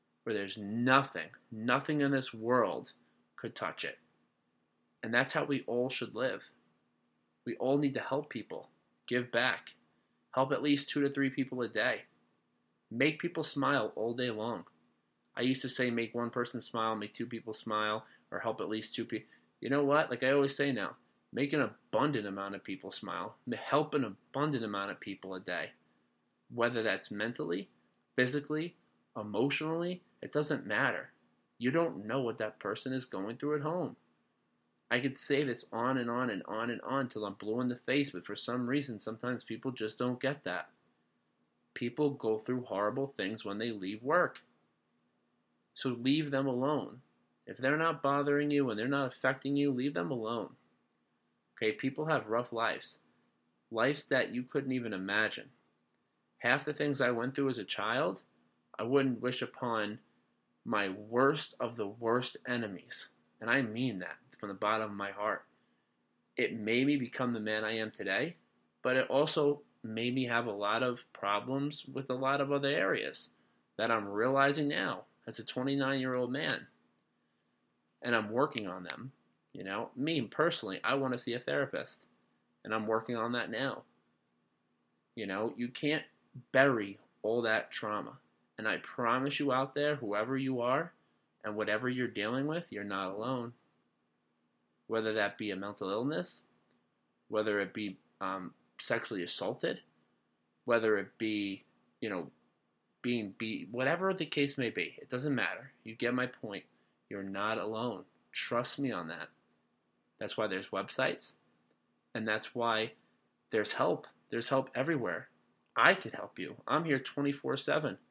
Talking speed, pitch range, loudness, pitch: 170 wpm, 90-135 Hz, -34 LUFS, 115 Hz